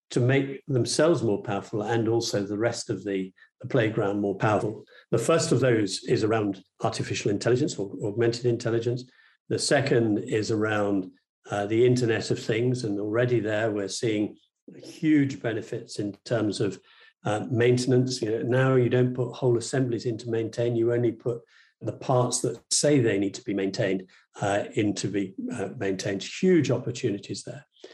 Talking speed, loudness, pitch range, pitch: 170 wpm, -26 LUFS, 105-125 Hz, 115 Hz